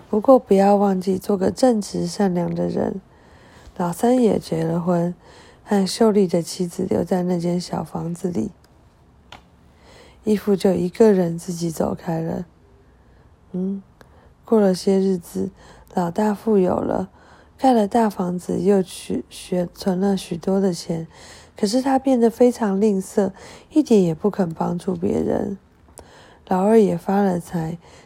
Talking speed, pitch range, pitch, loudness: 205 characters per minute, 175-210 Hz, 190 Hz, -20 LUFS